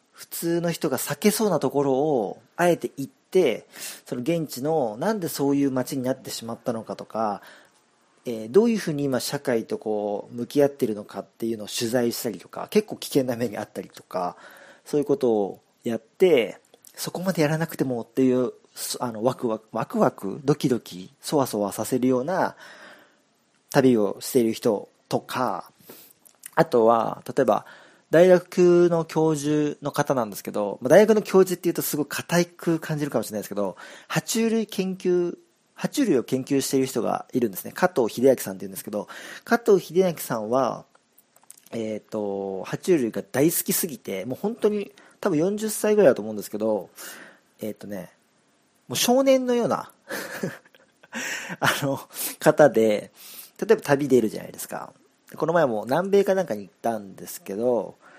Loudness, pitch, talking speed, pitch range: -24 LUFS, 145 Hz, 335 characters per minute, 120-180 Hz